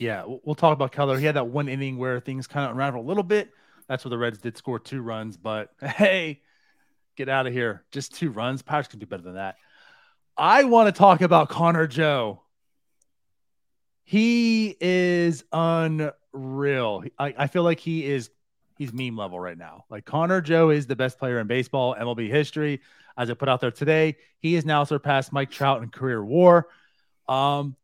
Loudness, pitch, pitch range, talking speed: -23 LUFS, 140 Hz, 125-165 Hz, 190 wpm